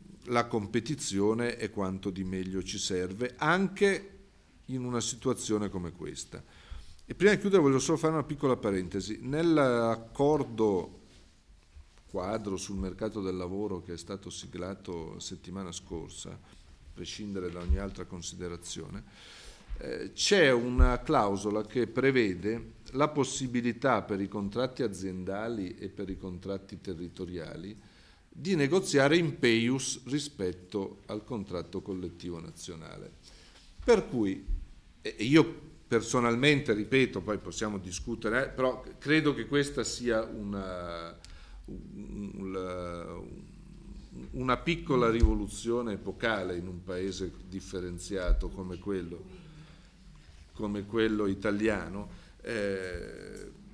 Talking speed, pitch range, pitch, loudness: 110 wpm, 90-120 Hz, 100 Hz, -31 LUFS